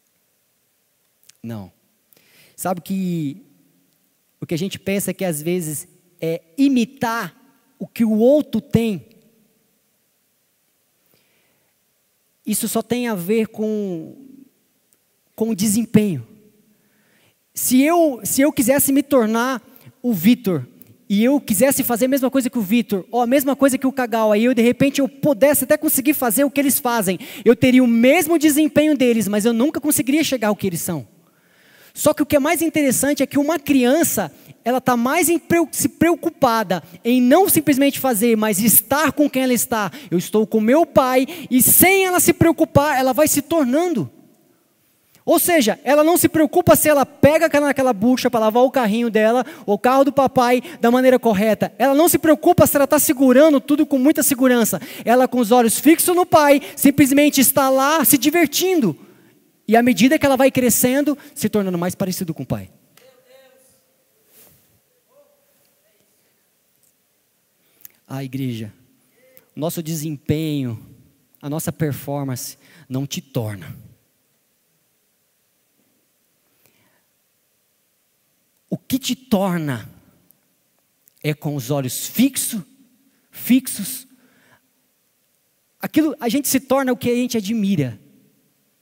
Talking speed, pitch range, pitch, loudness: 145 wpm, 210-280 Hz, 250 Hz, -17 LUFS